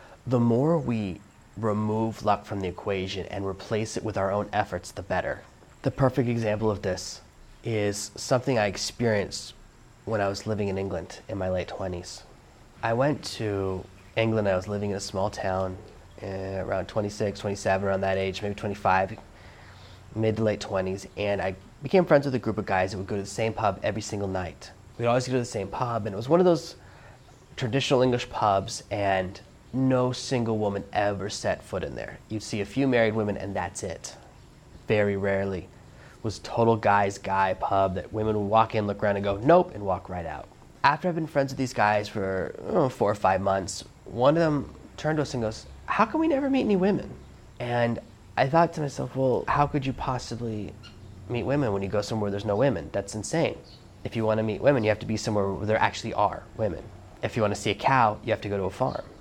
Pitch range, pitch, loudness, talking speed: 95-120 Hz, 105 Hz, -27 LUFS, 215 wpm